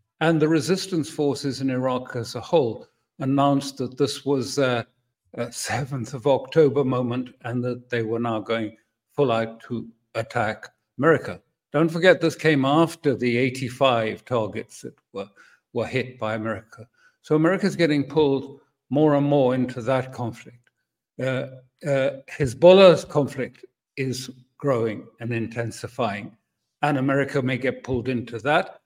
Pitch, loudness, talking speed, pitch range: 130 Hz, -23 LUFS, 145 wpm, 120-145 Hz